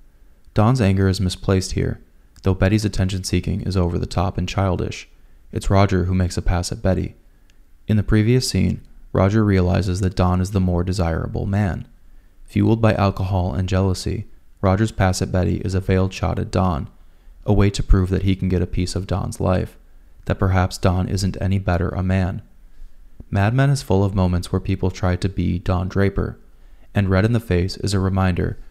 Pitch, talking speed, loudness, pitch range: 95 Hz, 190 wpm, -20 LUFS, 90-100 Hz